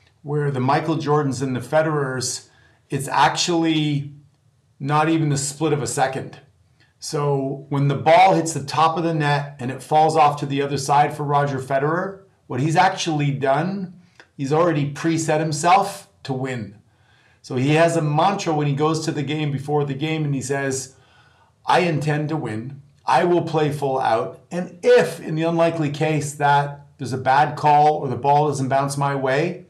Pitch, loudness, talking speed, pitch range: 145 Hz, -20 LUFS, 185 wpm, 135-155 Hz